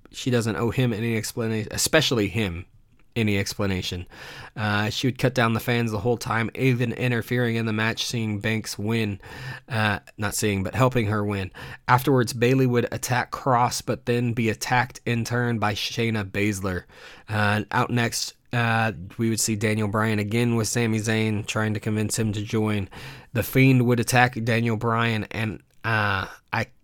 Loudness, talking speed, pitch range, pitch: -24 LUFS, 175 wpm, 105-120 Hz, 115 Hz